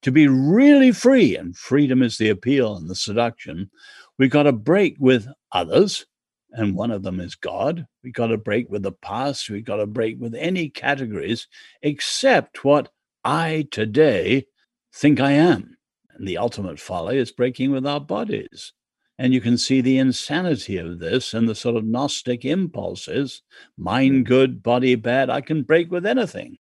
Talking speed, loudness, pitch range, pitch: 175 wpm, -20 LUFS, 115-150 Hz, 130 Hz